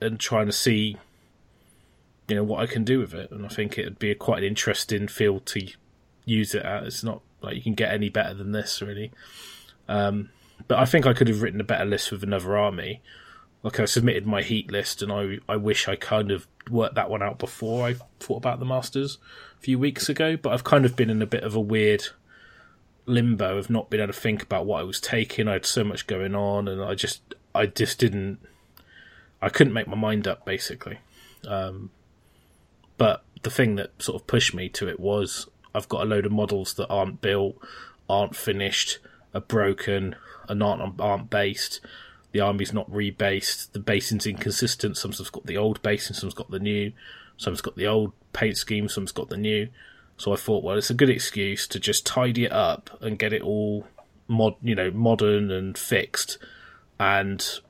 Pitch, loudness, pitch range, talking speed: 105 Hz, -25 LUFS, 100-115 Hz, 205 wpm